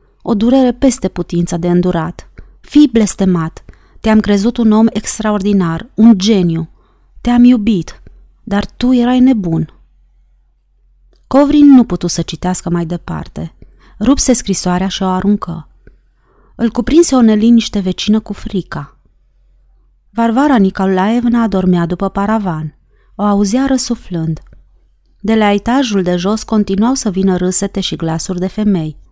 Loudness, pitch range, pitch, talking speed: -12 LUFS, 180-230 Hz, 205 Hz, 125 wpm